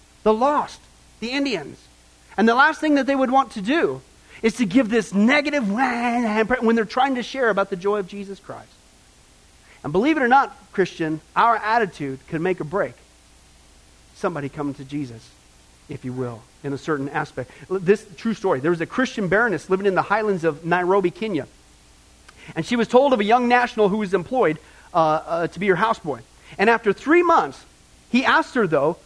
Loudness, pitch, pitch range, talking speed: -21 LUFS, 195 Hz, 145-235 Hz, 190 wpm